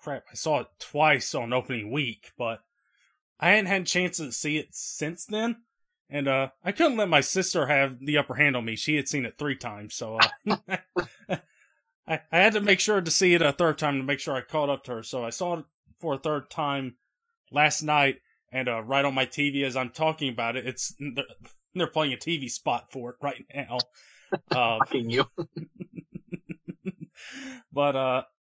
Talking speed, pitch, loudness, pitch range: 205 wpm, 145 Hz, -26 LUFS, 130-170 Hz